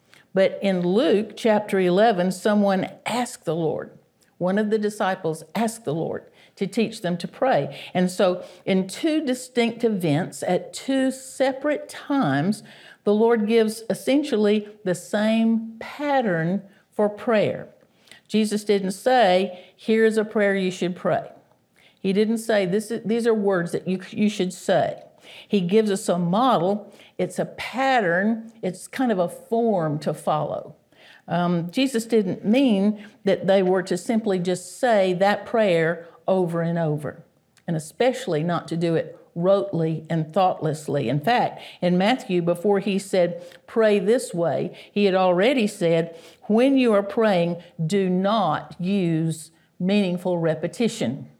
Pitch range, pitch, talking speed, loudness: 180-225 Hz, 195 Hz, 145 wpm, -23 LUFS